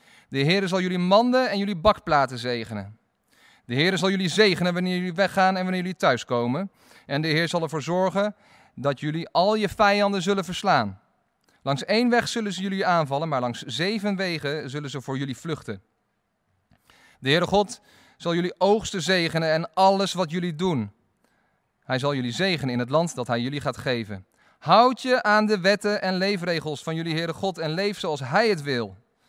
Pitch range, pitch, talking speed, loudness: 140-195 Hz, 175 Hz, 185 wpm, -24 LUFS